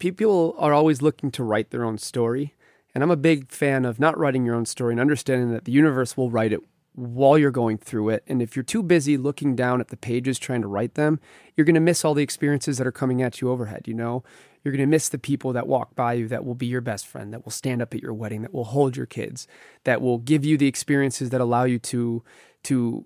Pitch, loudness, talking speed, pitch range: 130 Hz, -23 LUFS, 265 wpm, 120-145 Hz